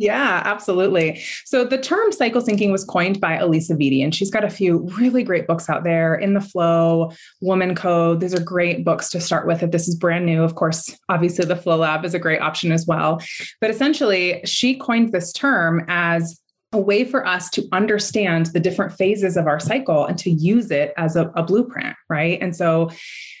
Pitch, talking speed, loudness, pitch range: 180 Hz, 210 wpm, -19 LUFS, 165-200 Hz